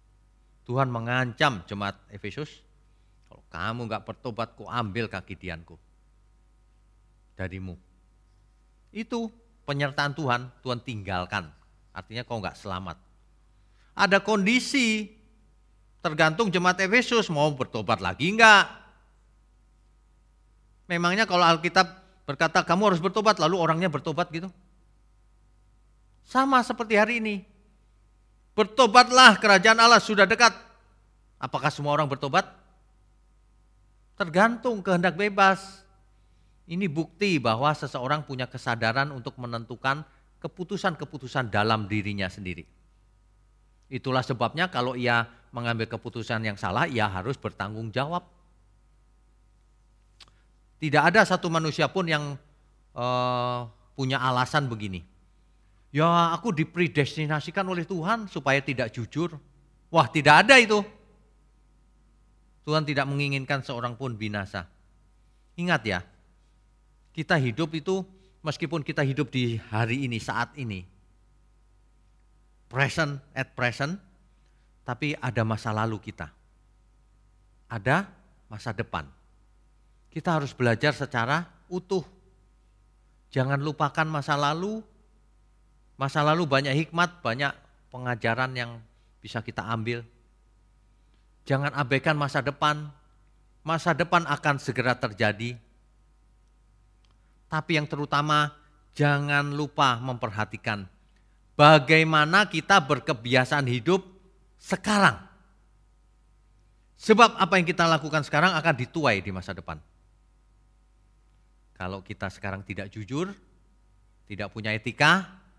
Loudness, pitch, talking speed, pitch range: -24 LUFS, 130 Hz, 100 wpm, 105-165 Hz